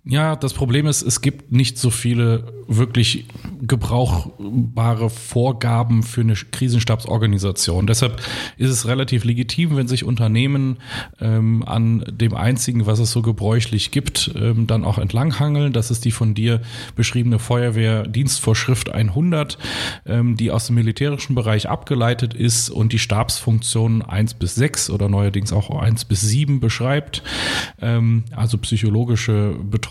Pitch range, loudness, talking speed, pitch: 110-125 Hz, -19 LUFS, 140 wpm, 115 Hz